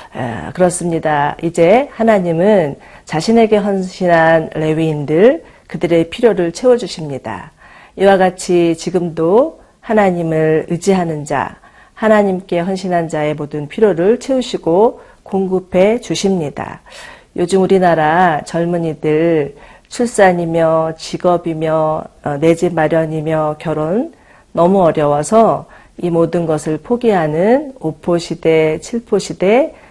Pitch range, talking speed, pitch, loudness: 160-195 Hz, 255 characters per minute, 175 Hz, -14 LUFS